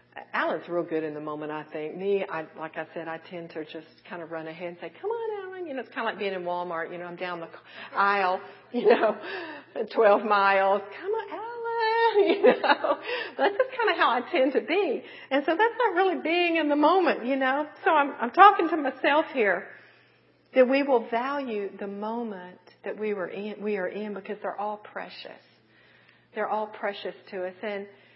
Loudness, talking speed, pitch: -26 LUFS, 215 wpm, 210 Hz